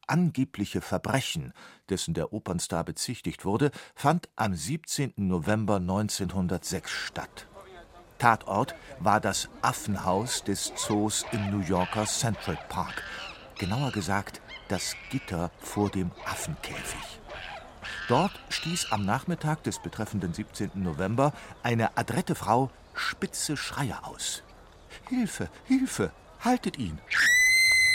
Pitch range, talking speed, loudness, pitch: 95-140 Hz, 105 wpm, -29 LUFS, 105 Hz